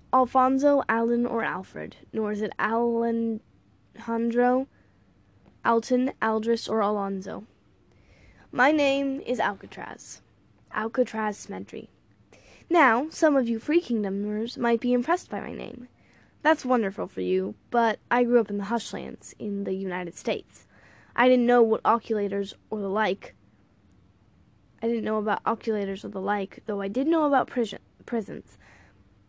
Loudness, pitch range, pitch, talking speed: -26 LUFS, 195-245 Hz, 225 Hz, 140 wpm